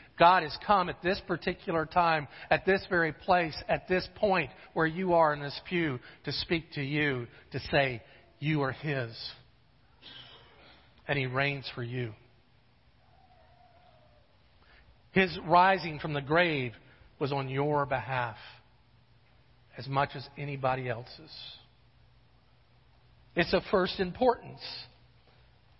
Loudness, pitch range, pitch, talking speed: -30 LUFS, 125-170 Hz, 145 Hz, 120 wpm